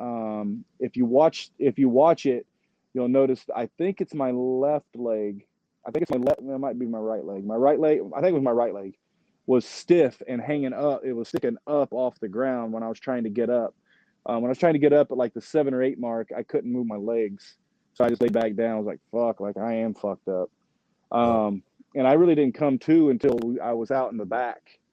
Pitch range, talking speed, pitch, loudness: 115-140 Hz, 255 wpm, 125 Hz, -25 LUFS